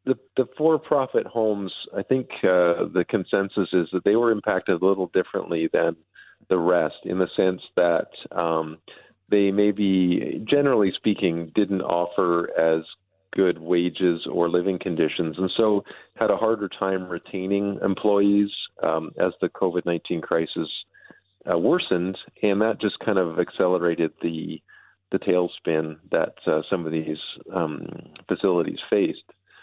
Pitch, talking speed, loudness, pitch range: 95 Hz, 145 wpm, -24 LUFS, 85-105 Hz